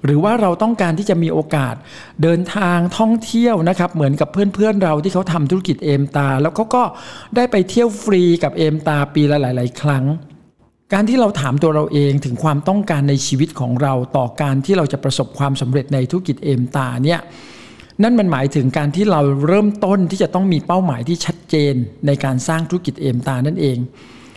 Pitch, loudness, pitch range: 155 Hz, -16 LUFS, 140-185 Hz